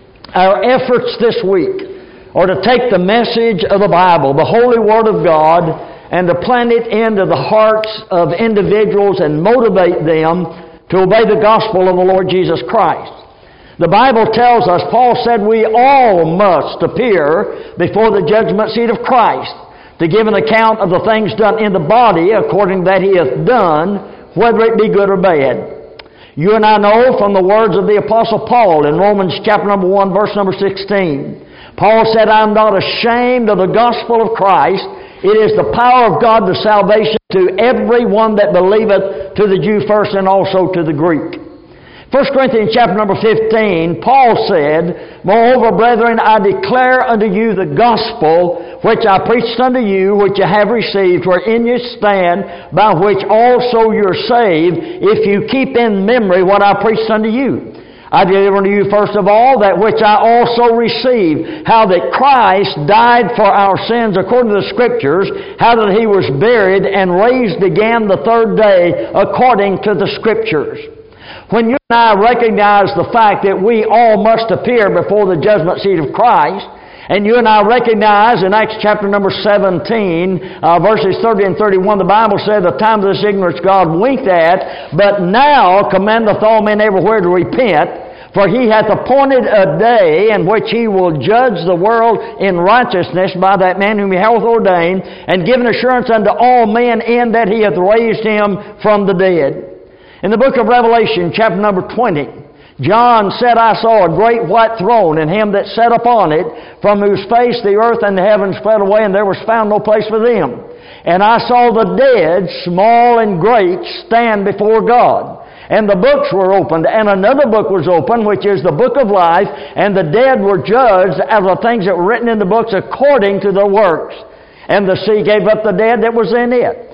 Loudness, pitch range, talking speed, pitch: -10 LUFS, 195-230 Hz, 185 wpm, 215 Hz